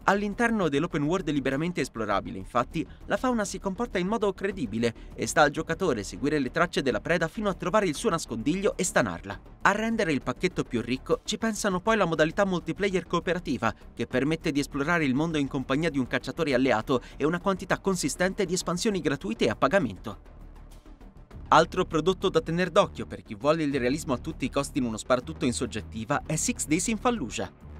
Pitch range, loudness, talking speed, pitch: 125-190 Hz, -27 LUFS, 190 wpm, 155 Hz